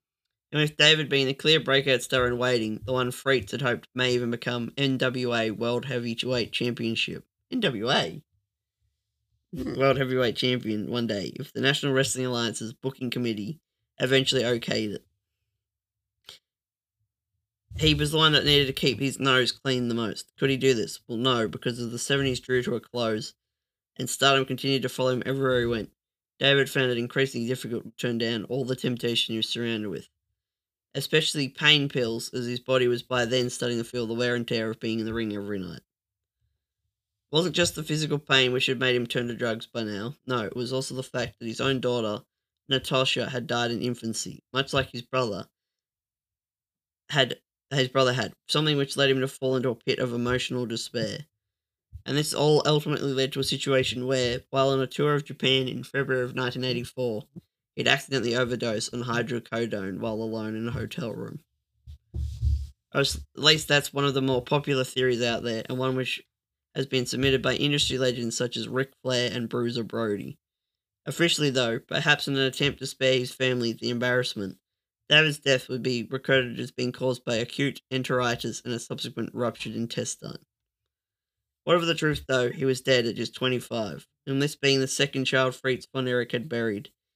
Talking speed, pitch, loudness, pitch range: 185 wpm, 125 Hz, -26 LUFS, 115-135 Hz